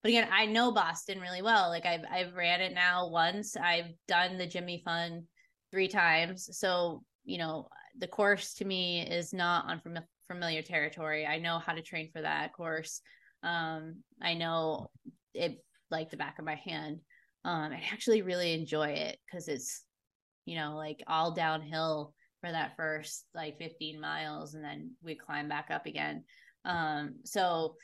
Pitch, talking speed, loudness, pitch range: 165 Hz, 170 wpm, -33 LUFS, 155-180 Hz